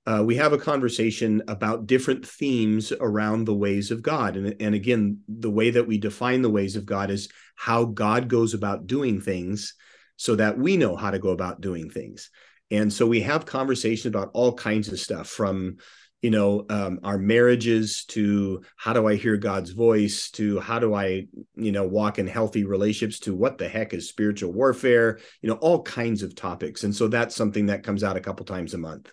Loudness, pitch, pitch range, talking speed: -24 LUFS, 105 Hz, 100-115 Hz, 205 wpm